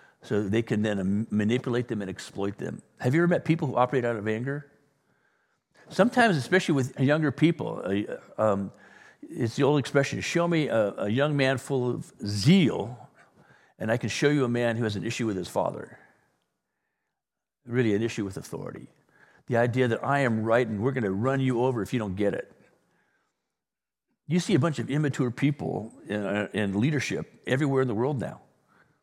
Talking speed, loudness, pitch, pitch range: 190 wpm, -27 LUFS, 125 Hz, 110-145 Hz